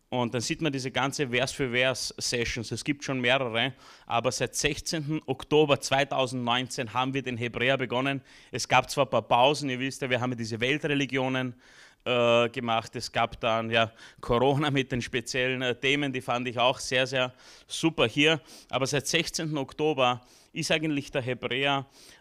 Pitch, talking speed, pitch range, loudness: 130 Hz, 170 wpm, 125-140 Hz, -27 LUFS